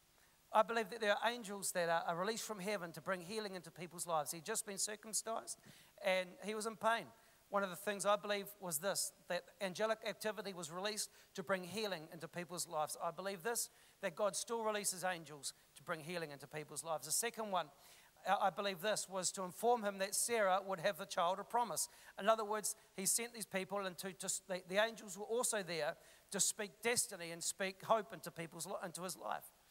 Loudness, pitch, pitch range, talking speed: -40 LUFS, 195 Hz, 180-215 Hz, 205 wpm